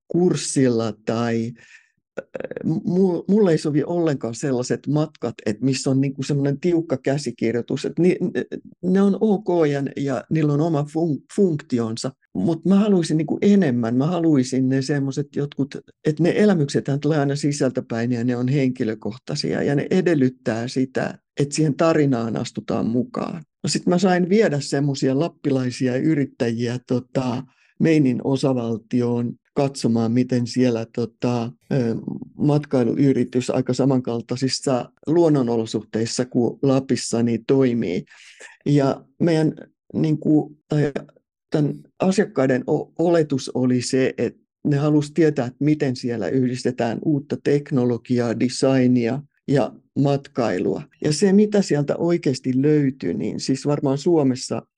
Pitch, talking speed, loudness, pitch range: 135 Hz, 115 wpm, -21 LUFS, 125-155 Hz